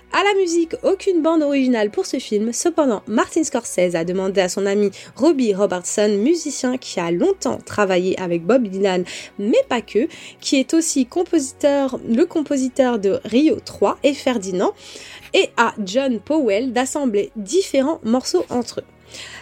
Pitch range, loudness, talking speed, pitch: 205-305 Hz, -19 LUFS, 155 wpm, 255 Hz